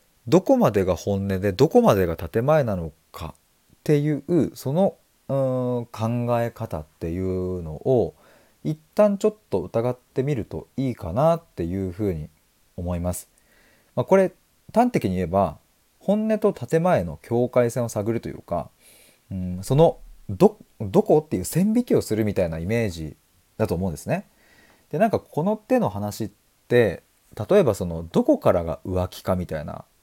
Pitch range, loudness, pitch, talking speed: 90-155 Hz, -23 LUFS, 115 Hz, 300 characters per minute